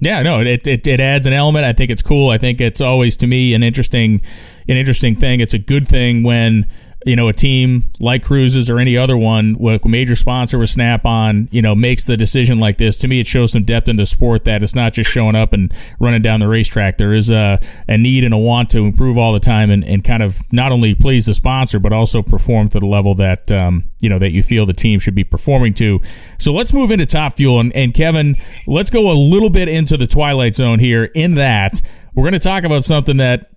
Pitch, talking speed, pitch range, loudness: 120 Hz, 250 wpm, 110-130 Hz, -13 LUFS